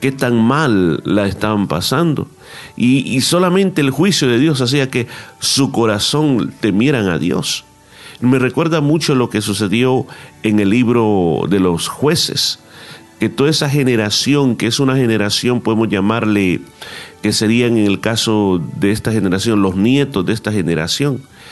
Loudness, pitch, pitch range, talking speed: -15 LUFS, 115 Hz, 105-135 Hz, 155 wpm